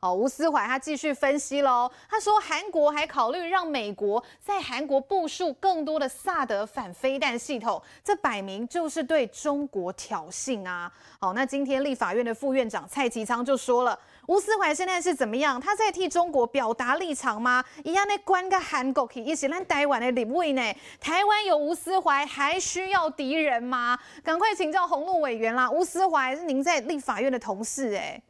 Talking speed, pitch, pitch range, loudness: 280 characters per minute, 285 Hz, 250-345 Hz, -26 LUFS